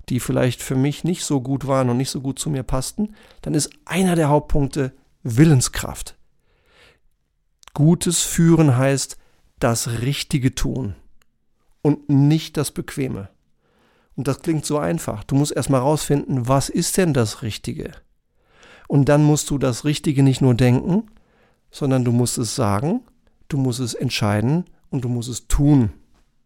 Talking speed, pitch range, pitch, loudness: 155 wpm, 125-155 Hz, 140 Hz, -20 LUFS